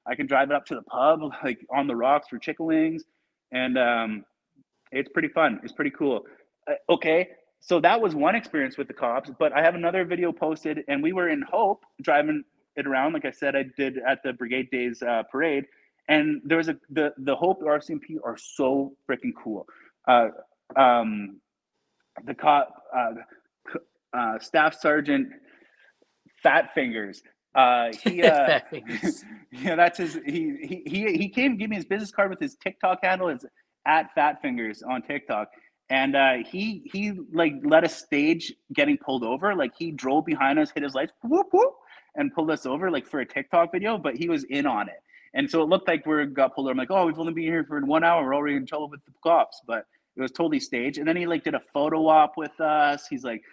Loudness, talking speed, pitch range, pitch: -25 LUFS, 205 wpm, 140-190 Hz, 160 Hz